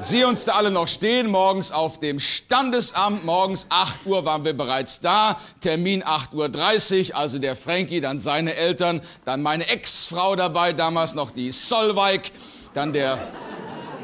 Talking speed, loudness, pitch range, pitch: 155 wpm, -20 LUFS, 150-195 Hz, 175 Hz